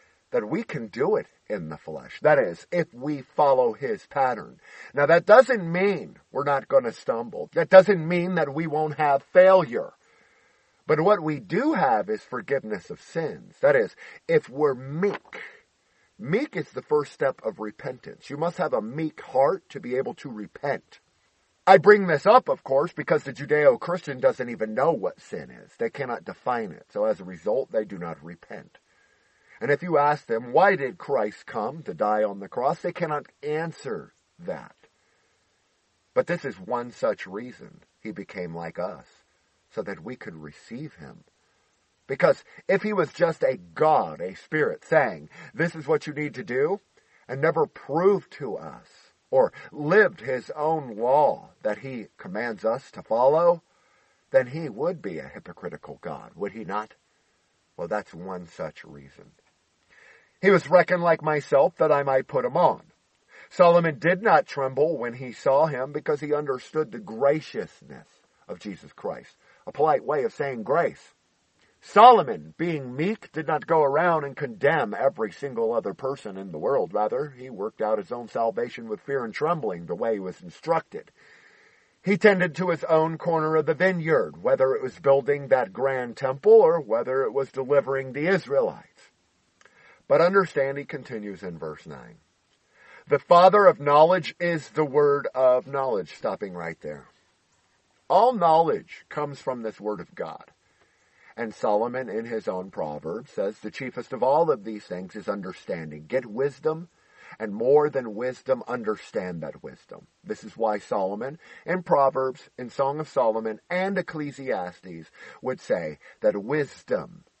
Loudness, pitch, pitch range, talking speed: -24 LUFS, 155 Hz, 130-190 Hz, 170 wpm